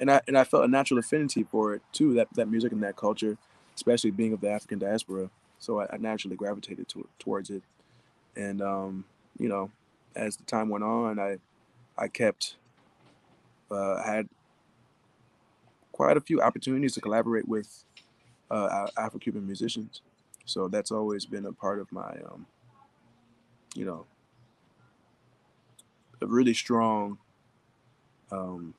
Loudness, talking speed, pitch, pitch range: -29 LUFS, 150 wpm, 110 Hz, 100-115 Hz